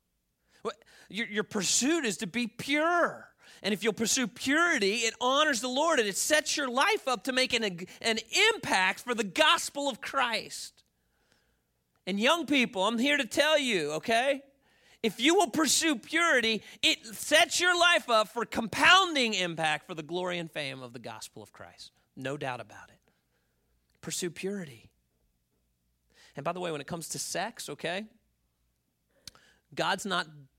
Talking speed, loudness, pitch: 165 wpm, -27 LUFS, 220 Hz